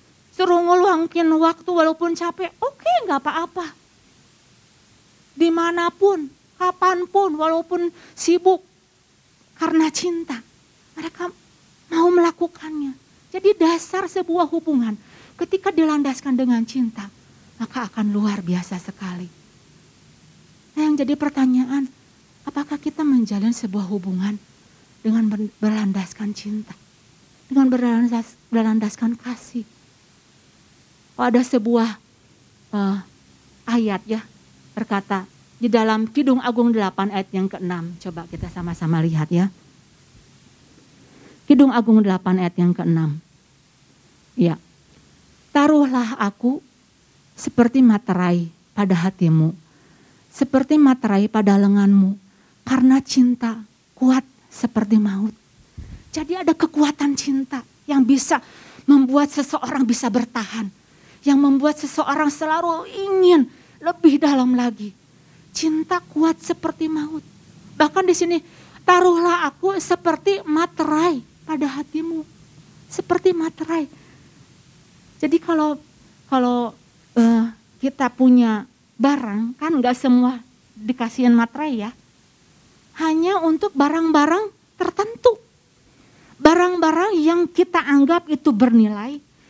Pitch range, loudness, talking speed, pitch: 220-325 Hz, -19 LUFS, 100 wpm, 270 Hz